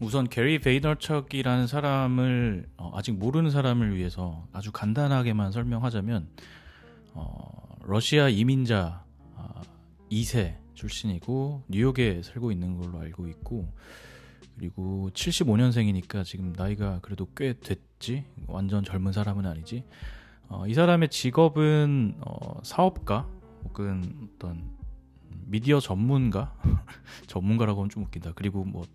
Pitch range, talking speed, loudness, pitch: 90-125 Hz, 270 characters per minute, -27 LUFS, 105 Hz